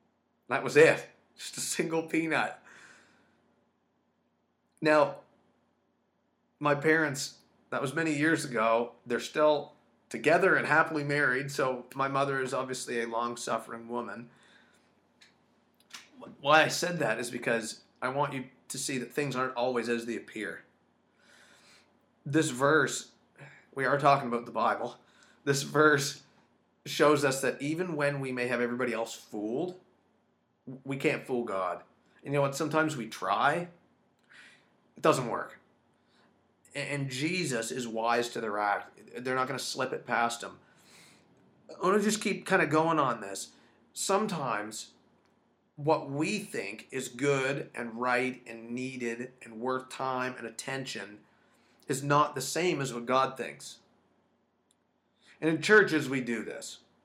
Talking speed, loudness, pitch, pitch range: 145 wpm, -30 LUFS, 135 Hz, 120-150 Hz